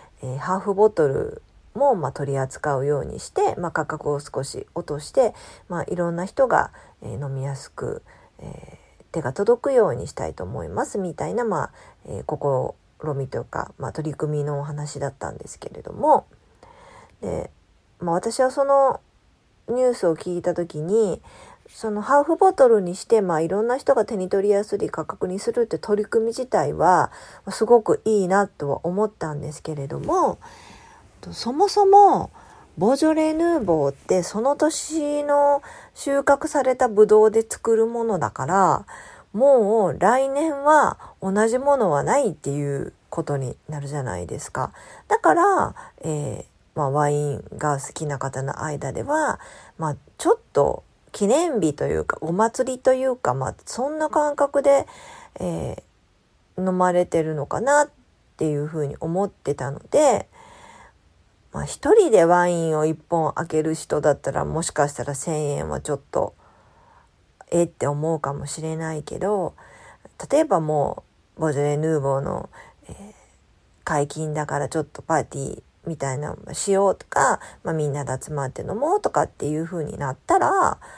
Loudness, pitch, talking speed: -22 LUFS, 180 Hz, 290 characters per minute